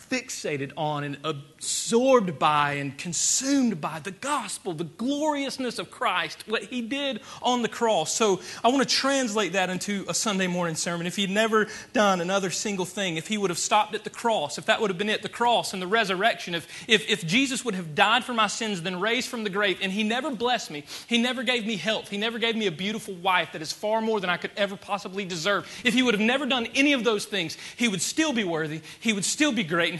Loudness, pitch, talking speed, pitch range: -25 LUFS, 210 Hz, 240 wpm, 180-235 Hz